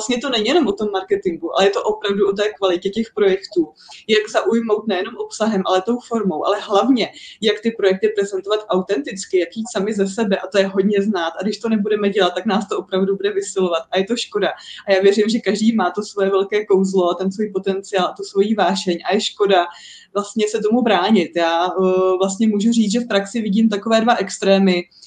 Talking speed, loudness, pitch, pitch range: 215 wpm, -18 LUFS, 200 Hz, 190-215 Hz